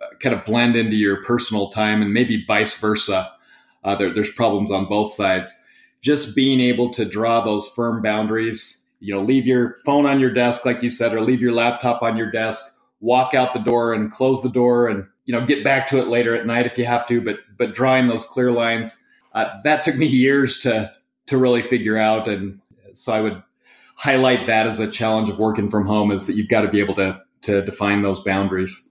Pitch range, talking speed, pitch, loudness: 105-125 Hz, 220 wpm, 115 Hz, -19 LUFS